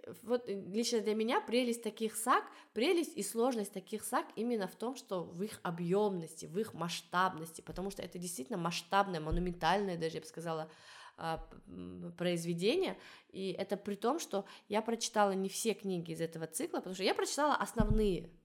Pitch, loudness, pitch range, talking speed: 195 Hz, -36 LUFS, 175-225 Hz, 165 wpm